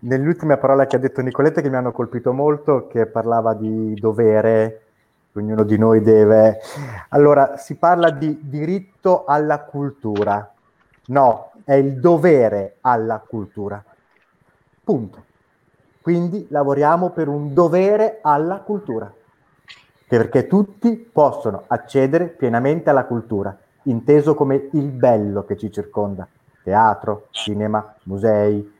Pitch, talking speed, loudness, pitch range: 130 Hz, 120 wpm, -18 LUFS, 110-150 Hz